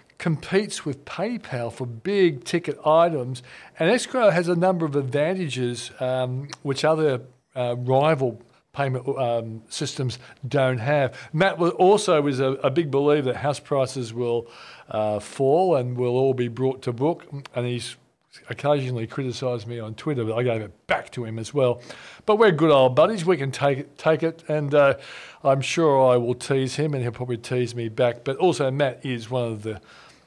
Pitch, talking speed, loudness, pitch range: 135 Hz, 185 wpm, -23 LUFS, 125-150 Hz